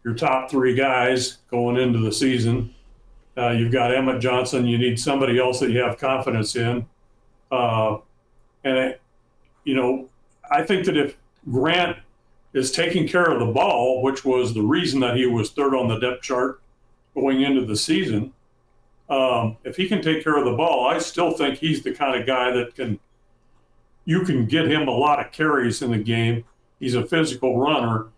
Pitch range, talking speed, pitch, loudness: 120-135 Hz, 185 wpm, 125 Hz, -21 LUFS